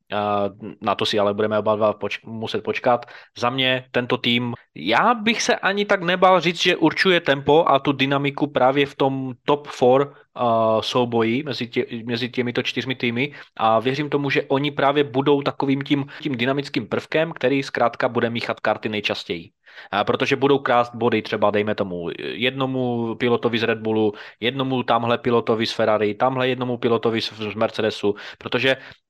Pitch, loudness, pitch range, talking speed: 125 Hz, -21 LUFS, 115-140 Hz, 170 wpm